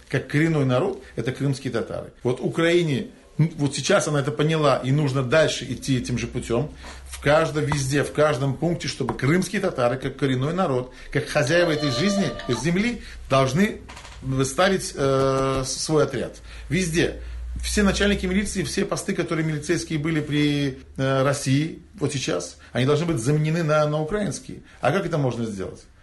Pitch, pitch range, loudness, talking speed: 150 Hz, 135-170 Hz, -23 LUFS, 160 wpm